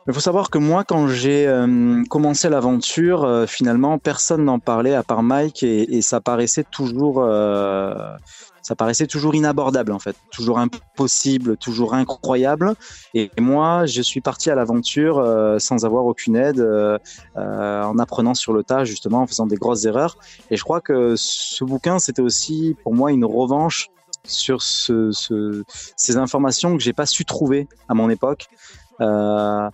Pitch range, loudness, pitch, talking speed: 115-150 Hz, -18 LUFS, 130 Hz, 170 wpm